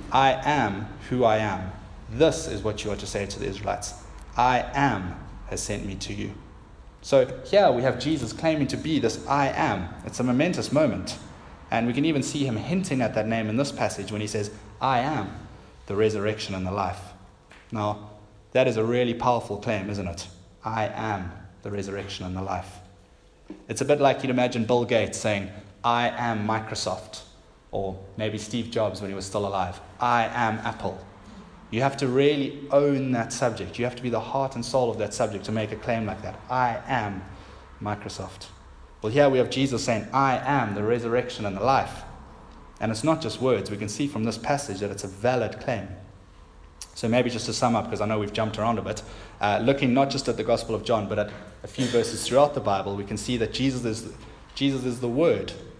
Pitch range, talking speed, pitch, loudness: 100-125 Hz, 210 wpm, 110 Hz, -26 LUFS